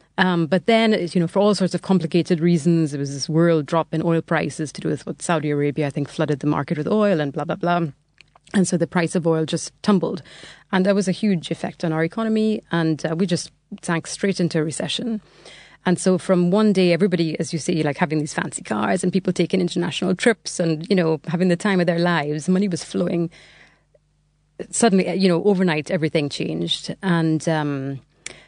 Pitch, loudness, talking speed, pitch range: 170 Hz, -21 LUFS, 215 wpm, 160-185 Hz